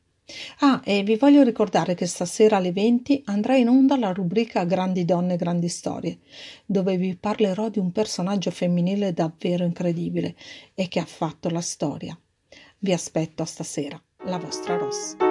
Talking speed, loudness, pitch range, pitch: 155 wpm, -23 LUFS, 175-215 Hz, 185 Hz